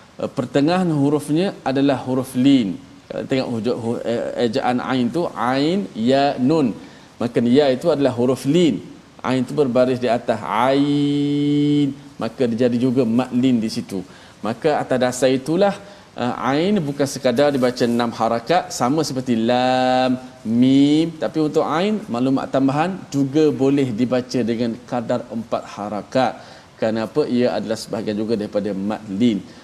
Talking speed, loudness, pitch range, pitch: 145 wpm, -19 LUFS, 120-145 Hz, 130 Hz